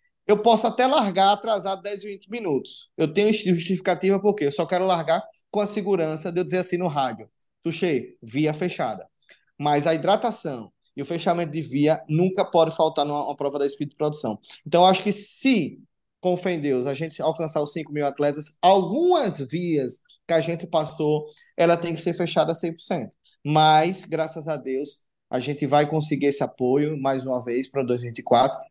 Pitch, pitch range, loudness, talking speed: 165 Hz, 145-185 Hz, -23 LUFS, 185 wpm